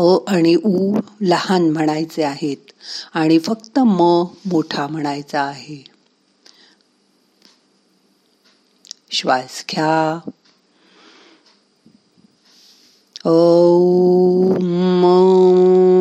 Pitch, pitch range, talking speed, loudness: 175 Hz, 155-185 Hz, 55 wpm, -16 LUFS